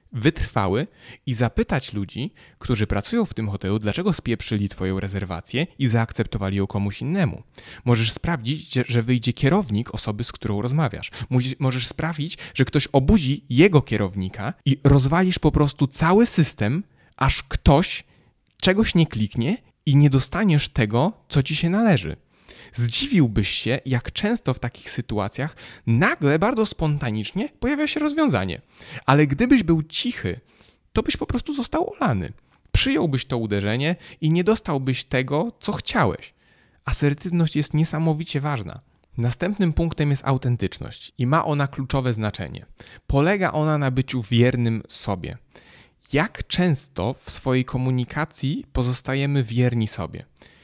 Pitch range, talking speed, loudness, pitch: 115-160 Hz, 135 wpm, -22 LUFS, 135 Hz